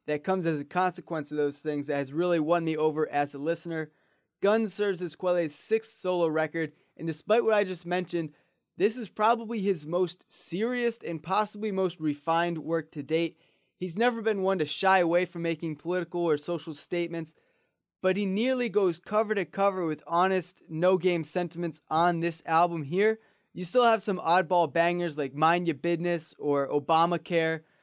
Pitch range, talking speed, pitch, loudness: 160-190 Hz, 180 wpm, 175 Hz, -28 LUFS